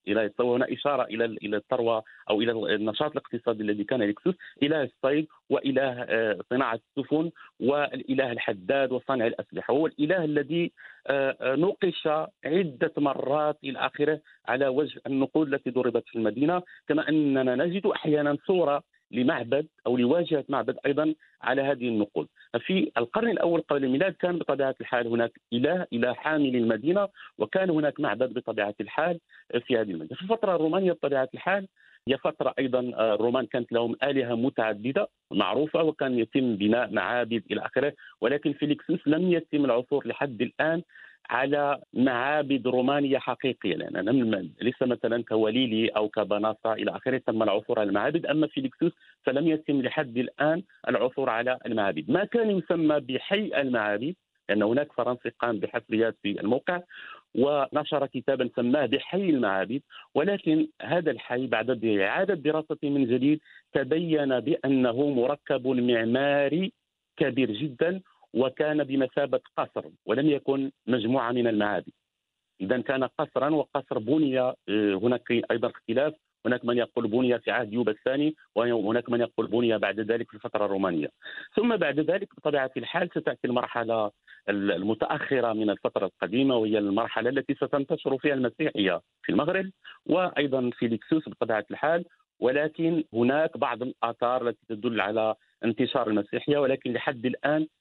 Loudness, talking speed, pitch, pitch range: -27 LUFS, 140 wpm, 130 Hz, 120-150 Hz